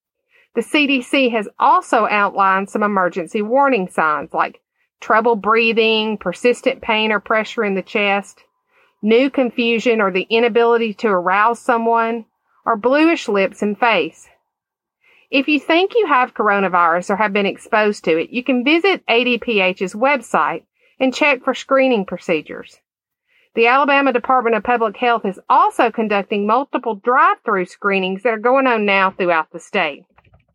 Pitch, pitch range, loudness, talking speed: 230 Hz, 205-270 Hz, -16 LUFS, 145 wpm